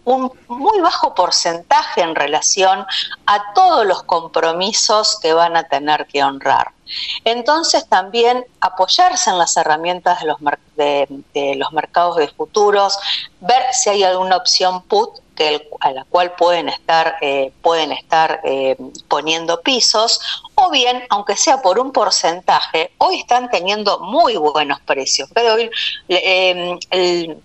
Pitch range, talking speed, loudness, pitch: 160-240 Hz, 145 wpm, -15 LUFS, 185 Hz